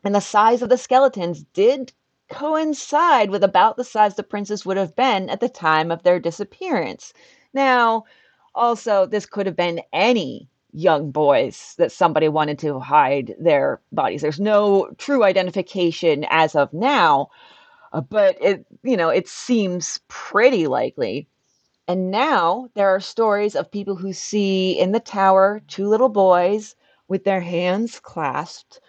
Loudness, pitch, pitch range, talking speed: -19 LUFS, 200 Hz, 180-245 Hz, 150 wpm